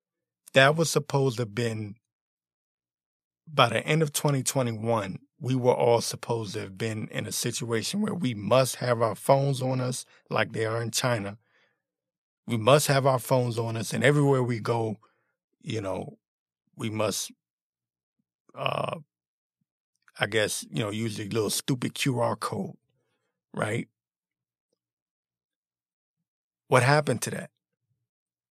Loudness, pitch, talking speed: -27 LUFS, 115 Hz, 145 wpm